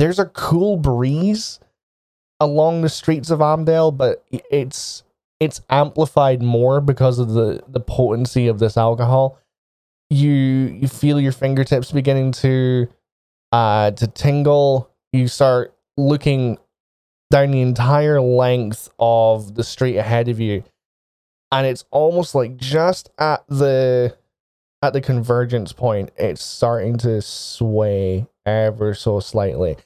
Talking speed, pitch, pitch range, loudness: 125 wpm, 130 Hz, 115-145 Hz, -18 LUFS